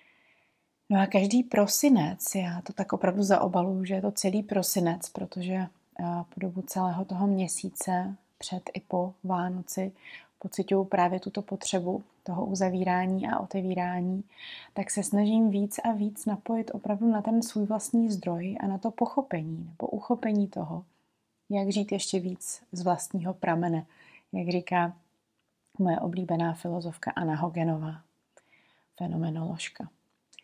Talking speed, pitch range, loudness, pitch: 130 wpm, 180-205 Hz, -29 LUFS, 190 Hz